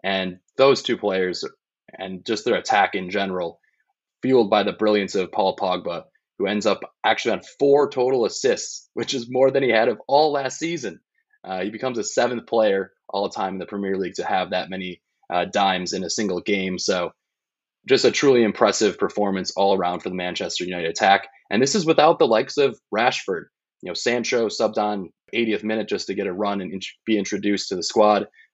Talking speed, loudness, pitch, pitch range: 205 wpm, -22 LUFS, 105 Hz, 95-130 Hz